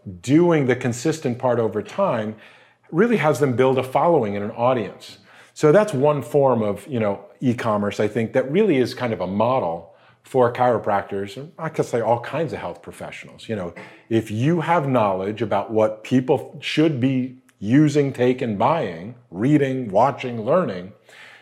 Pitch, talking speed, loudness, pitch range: 125 Hz, 170 wpm, -21 LUFS, 110-150 Hz